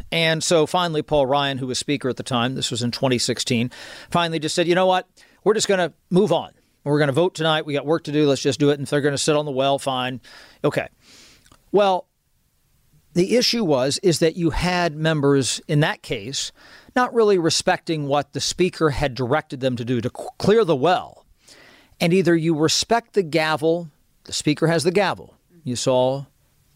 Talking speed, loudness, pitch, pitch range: 205 wpm, -21 LUFS, 155 Hz, 135-175 Hz